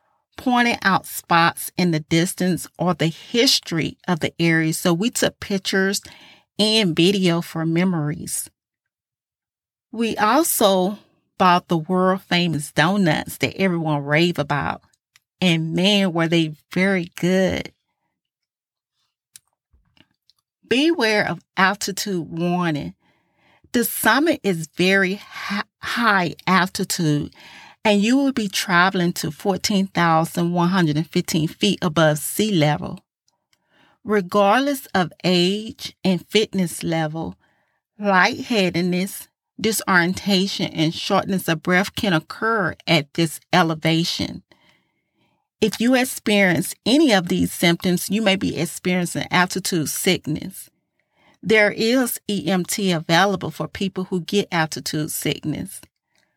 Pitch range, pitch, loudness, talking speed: 165-200 Hz, 180 Hz, -20 LUFS, 105 wpm